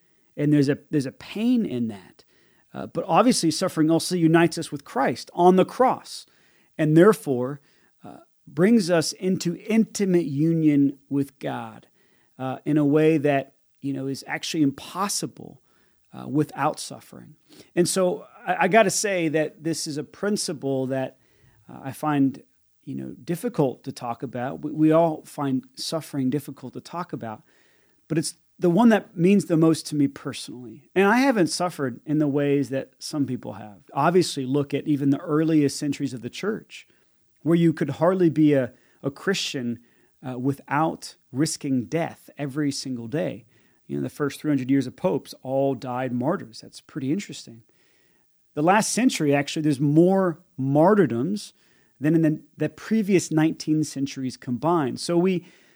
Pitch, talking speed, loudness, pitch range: 150 Hz, 165 wpm, -23 LUFS, 135-170 Hz